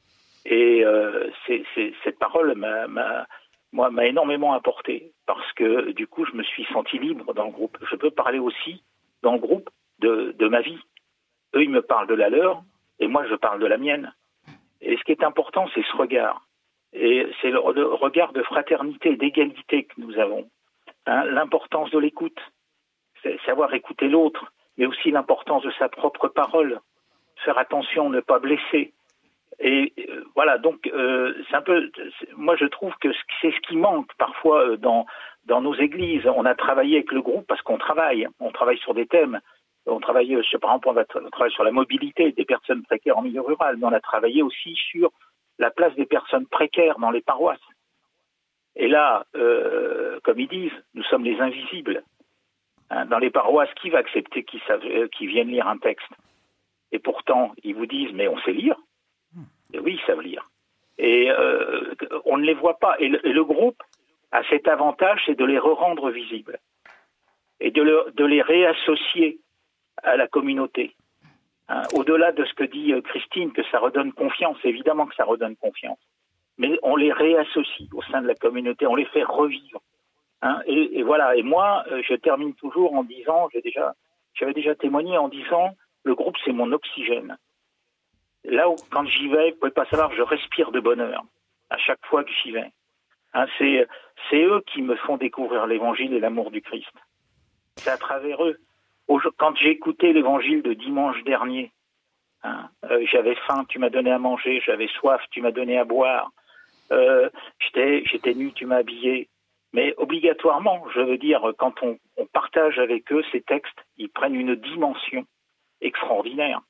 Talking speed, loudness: 190 wpm, -22 LUFS